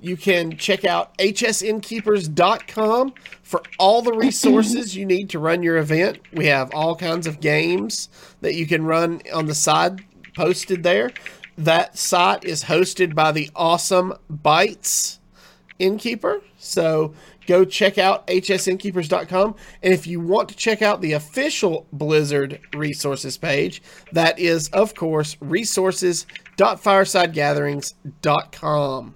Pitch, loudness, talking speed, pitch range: 180 Hz, -20 LUFS, 125 wpm, 155-195 Hz